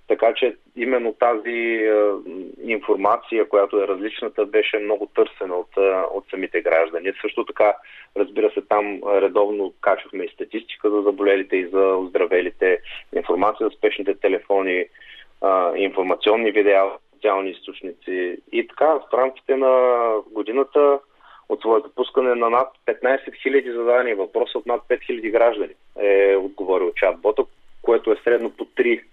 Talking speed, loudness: 140 wpm, -20 LUFS